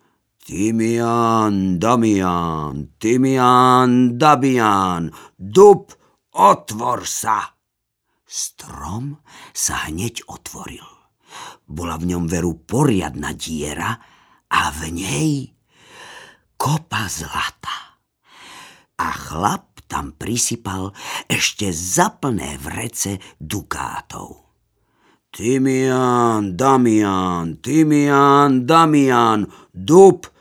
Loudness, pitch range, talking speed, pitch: -17 LUFS, 90-130 Hz, 70 wpm, 115 Hz